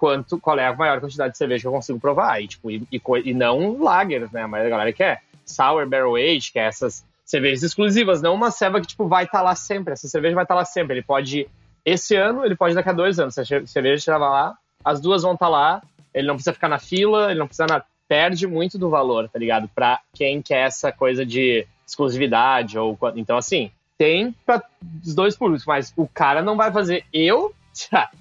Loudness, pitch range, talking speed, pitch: -20 LUFS, 135-185 Hz, 230 wpm, 160 Hz